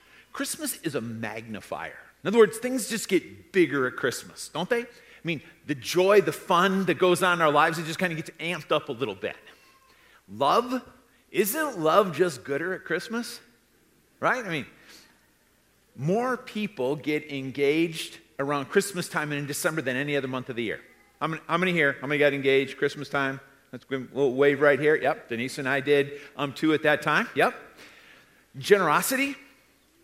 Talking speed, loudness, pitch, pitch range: 185 wpm, -26 LUFS, 155 Hz, 140-190 Hz